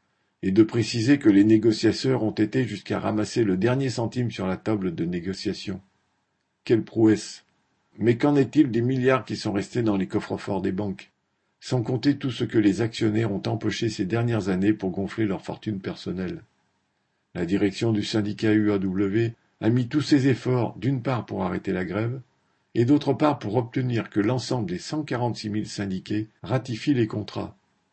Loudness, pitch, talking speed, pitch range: -25 LUFS, 110 Hz, 180 wpm, 105-125 Hz